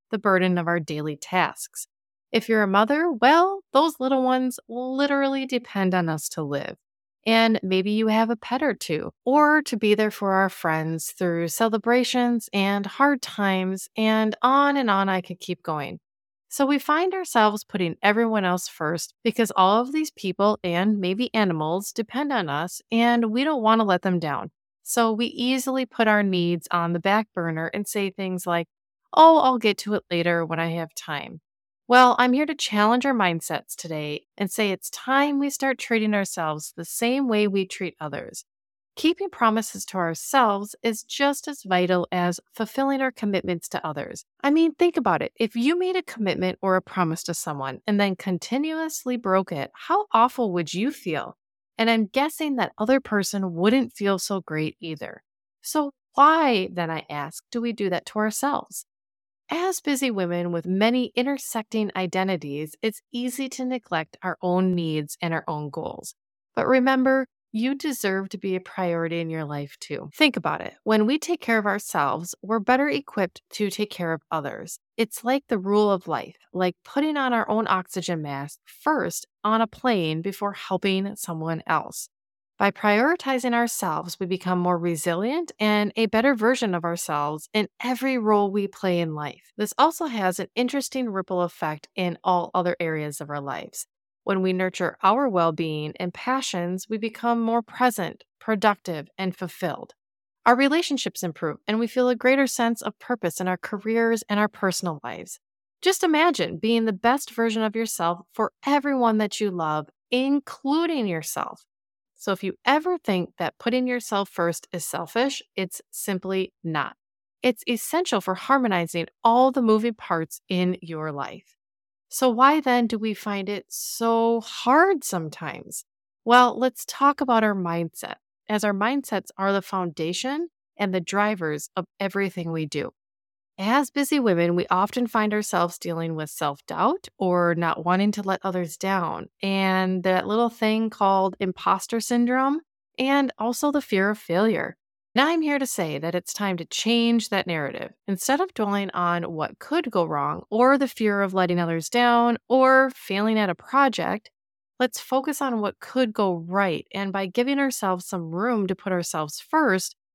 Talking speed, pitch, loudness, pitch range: 175 wpm, 205 Hz, -24 LUFS, 180-245 Hz